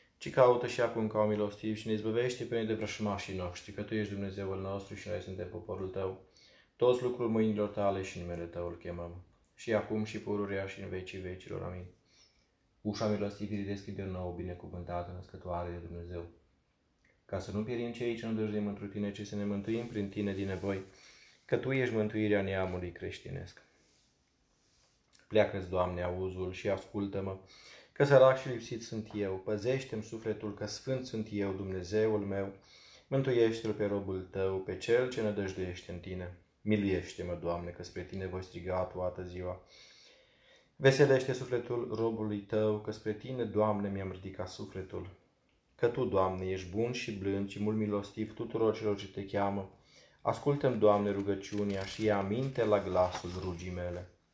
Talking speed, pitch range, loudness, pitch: 165 wpm, 95-110 Hz, -34 LUFS, 100 Hz